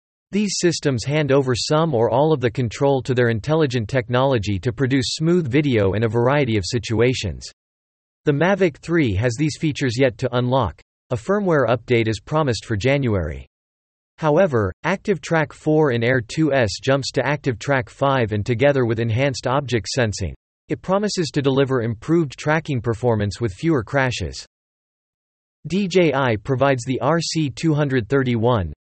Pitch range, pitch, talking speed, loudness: 110-150 Hz, 130 Hz, 150 wpm, -20 LUFS